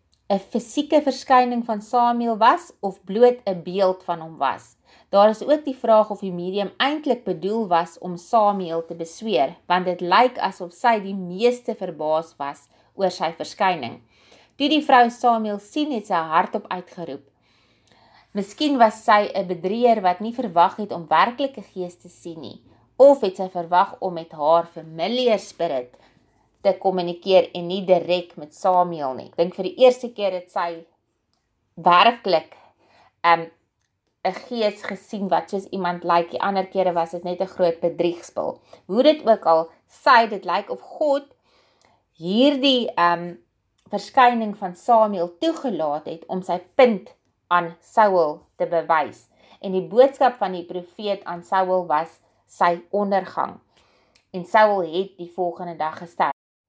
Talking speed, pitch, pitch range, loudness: 160 wpm, 185 Hz, 170-220 Hz, -21 LUFS